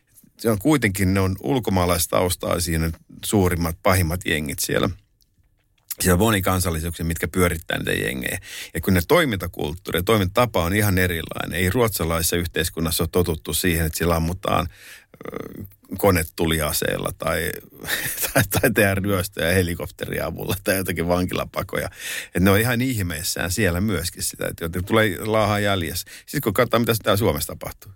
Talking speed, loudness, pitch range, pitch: 150 wpm, -22 LUFS, 85-105 Hz, 95 Hz